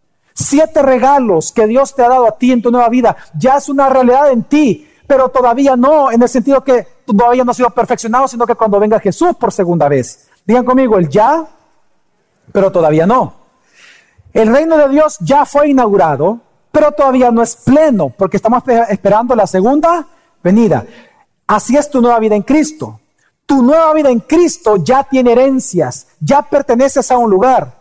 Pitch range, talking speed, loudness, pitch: 220-280 Hz, 180 wpm, -11 LUFS, 250 Hz